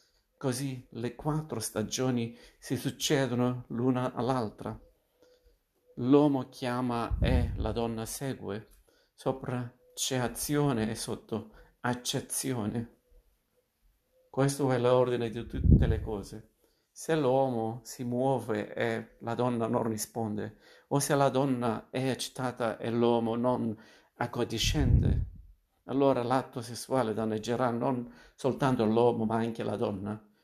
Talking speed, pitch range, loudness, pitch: 110 wpm, 110-130 Hz, -31 LUFS, 120 Hz